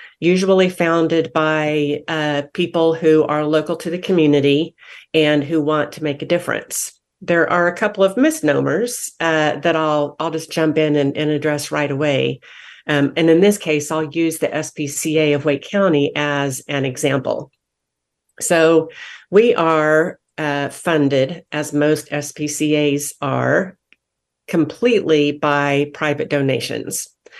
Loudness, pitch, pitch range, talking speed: -18 LUFS, 155 Hz, 145-165 Hz, 140 wpm